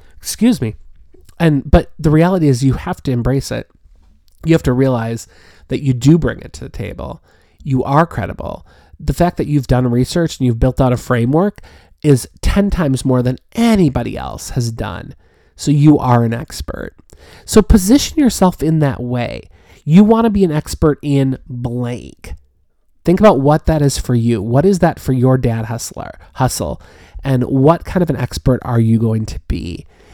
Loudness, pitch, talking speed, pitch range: -15 LUFS, 130 Hz, 185 wpm, 115-155 Hz